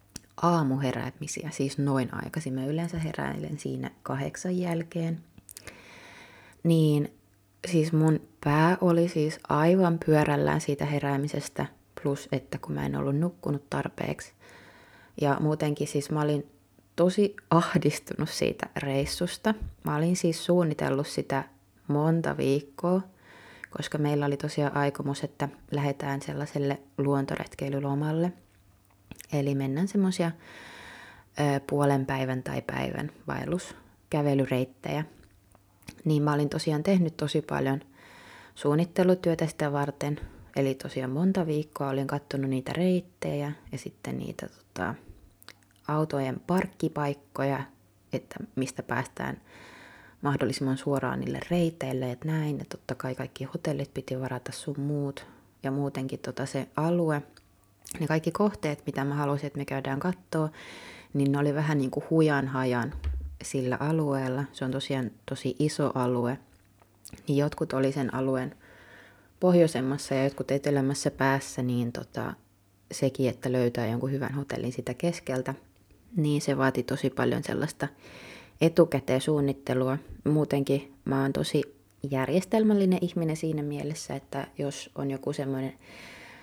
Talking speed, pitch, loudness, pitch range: 120 wpm, 140 Hz, -29 LUFS, 130-155 Hz